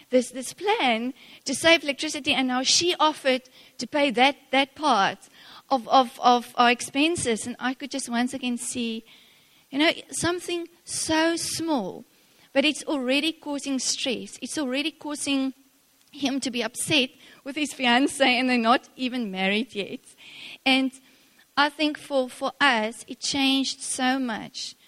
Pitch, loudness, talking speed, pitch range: 270 Hz, -24 LUFS, 150 wpm, 250-290 Hz